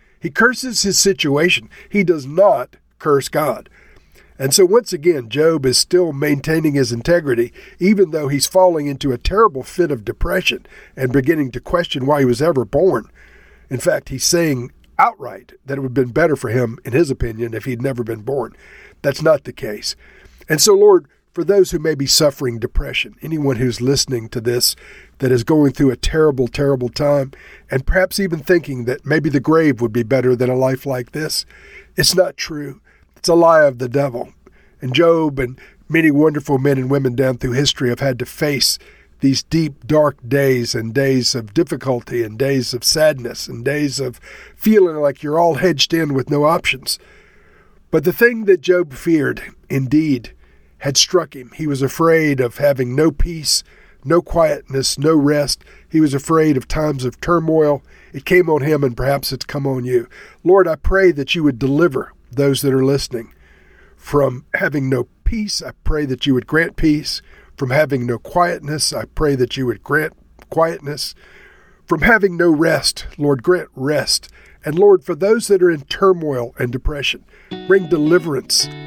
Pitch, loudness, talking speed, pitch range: 145 Hz, -16 LUFS, 185 wpm, 130-170 Hz